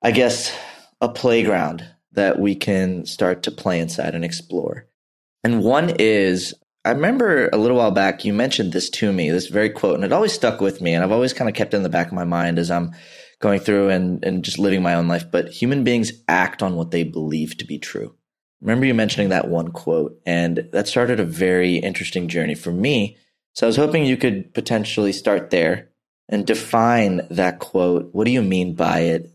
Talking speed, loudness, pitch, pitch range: 215 wpm, -20 LUFS, 95 Hz, 85-115 Hz